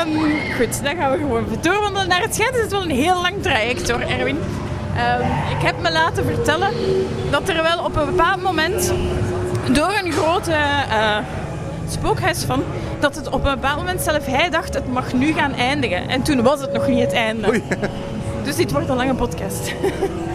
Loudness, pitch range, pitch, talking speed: -19 LUFS, 215-365 Hz, 300 Hz, 200 wpm